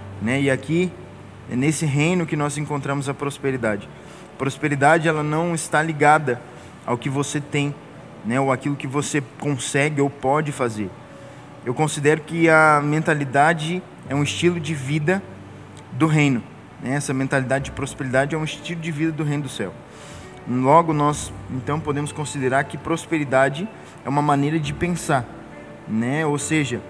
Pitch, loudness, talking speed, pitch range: 145 Hz, -21 LUFS, 155 wpm, 135-155 Hz